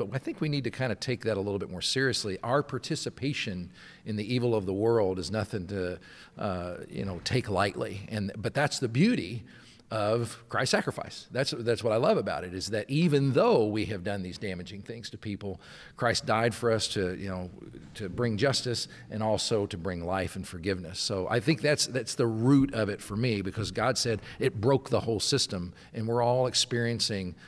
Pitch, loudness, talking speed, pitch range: 110 Hz, -29 LUFS, 215 wpm, 100-125 Hz